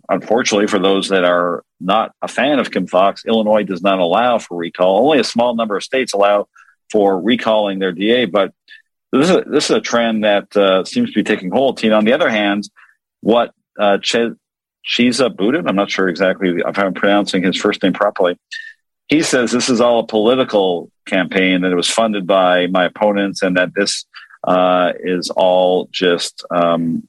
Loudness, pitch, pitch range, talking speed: -15 LUFS, 100 Hz, 95-115 Hz, 190 wpm